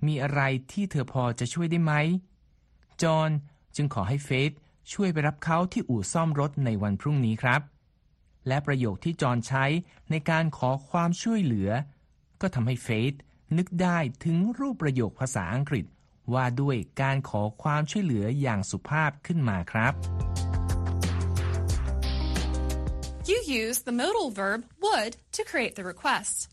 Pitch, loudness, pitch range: 135 Hz, -28 LUFS, 105-165 Hz